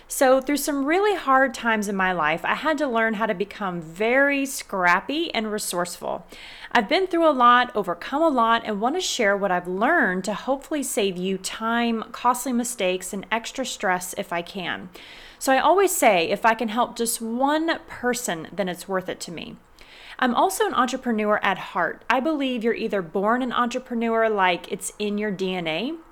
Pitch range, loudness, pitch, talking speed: 200-270 Hz, -23 LUFS, 230 Hz, 190 wpm